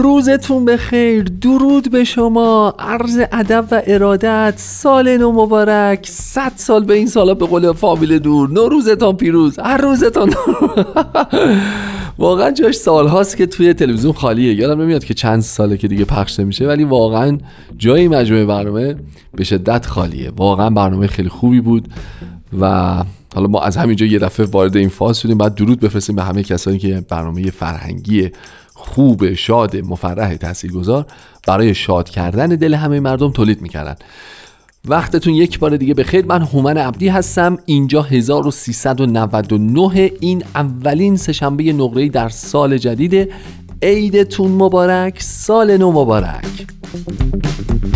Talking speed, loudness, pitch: 145 wpm, -13 LUFS, 145 Hz